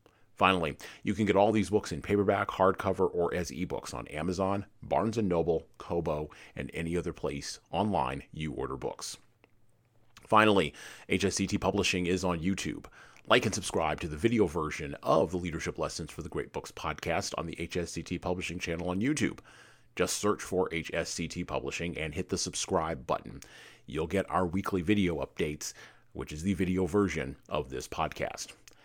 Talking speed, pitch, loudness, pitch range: 165 wpm, 90 Hz, -31 LUFS, 85-100 Hz